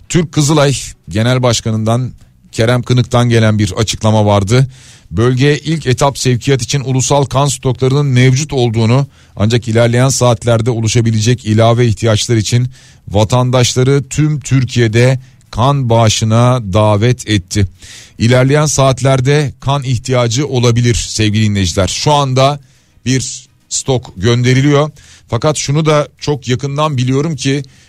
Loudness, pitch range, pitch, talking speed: -12 LUFS, 115-135 Hz, 125 Hz, 115 wpm